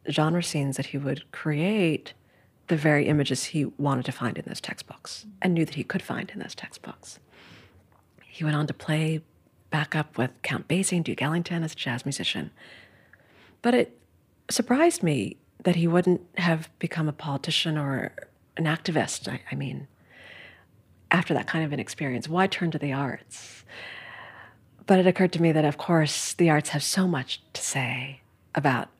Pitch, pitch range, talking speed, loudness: 155 Hz, 140-175 Hz, 180 wpm, -26 LUFS